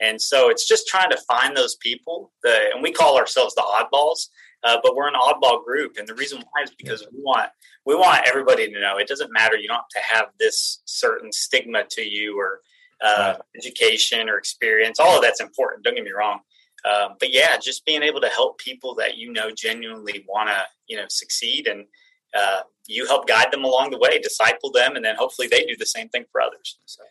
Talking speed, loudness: 225 wpm, -20 LUFS